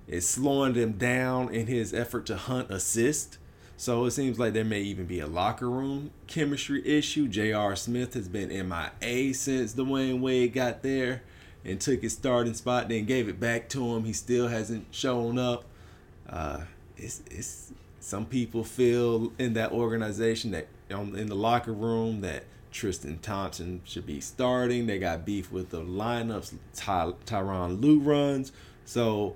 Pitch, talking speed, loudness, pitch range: 115 Hz, 170 wpm, -29 LUFS, 95-125 Hz